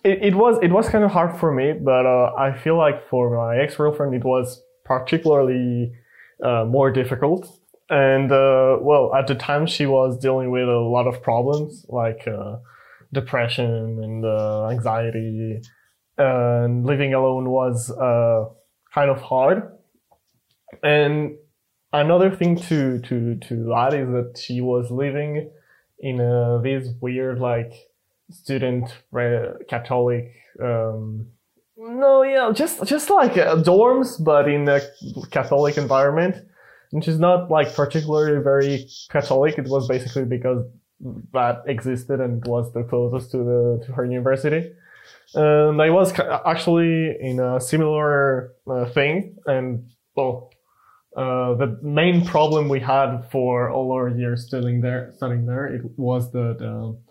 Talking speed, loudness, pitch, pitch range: 145 wpm, -20 LUFS, 130 Hz, 120-150 Hz